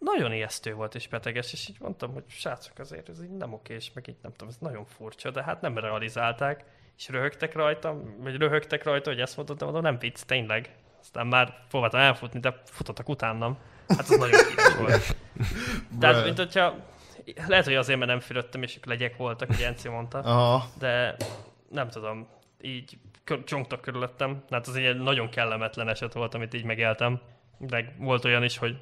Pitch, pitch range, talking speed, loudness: 125 Hz, 115-140 Hz, 185 wpm, -27 LUFS